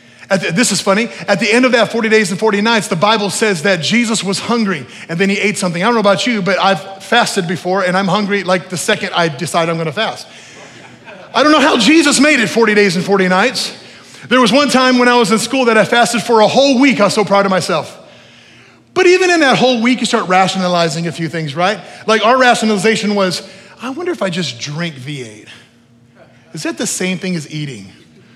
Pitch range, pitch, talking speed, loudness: 185-235 Hz, 200 Hz, 240 wpm, -13 LUFS